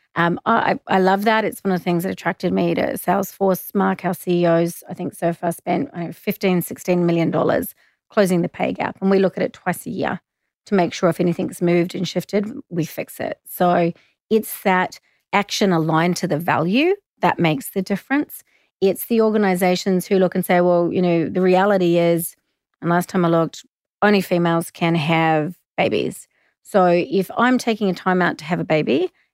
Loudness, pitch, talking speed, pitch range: -20 LUFS, 180 Hz, 200 wpm, 170-195 Hz